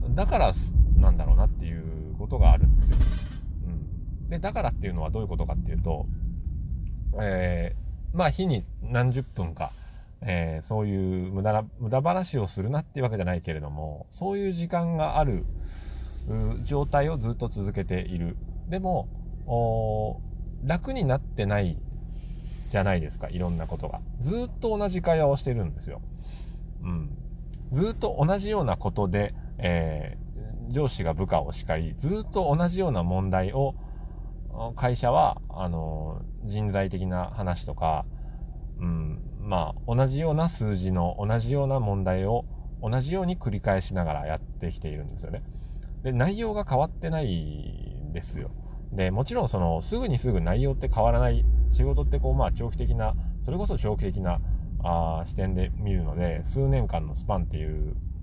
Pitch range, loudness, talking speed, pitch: 85-125 Hz, -28 LUFS, 320 characters per minute, 95 Hz